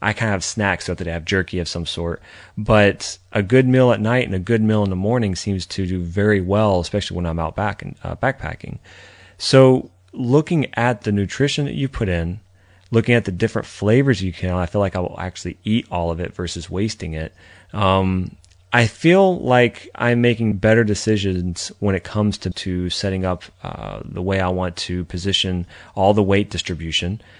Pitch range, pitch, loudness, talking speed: 90-110 Hz, 95 Hz, -19 LUFS, 205 wpm